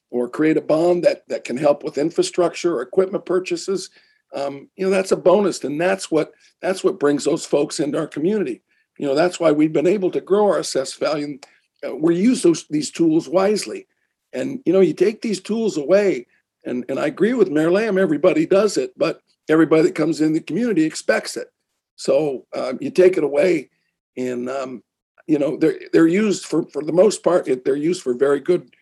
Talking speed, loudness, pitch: 210 wpm, -19 LUFS, 190 Hz